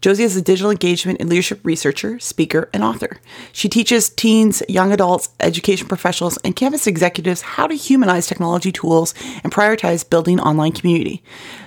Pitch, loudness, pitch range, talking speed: 185 Hz, -16 LUFS, 170-210 Hz, 160 wpm